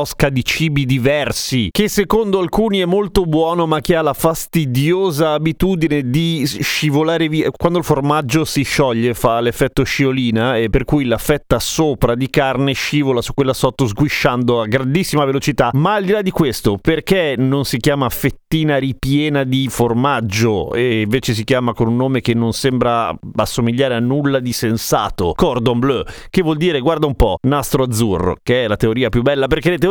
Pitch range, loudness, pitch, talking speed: 125-160 Hz, -16 LUFS, 140 Hz, 180 wpm